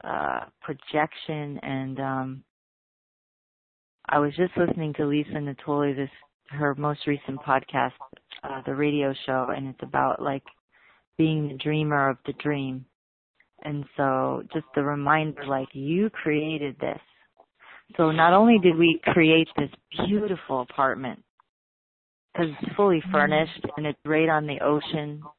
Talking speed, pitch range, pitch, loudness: 135 wpm, 135-155 Hz, 150 Hz, -25 LUFS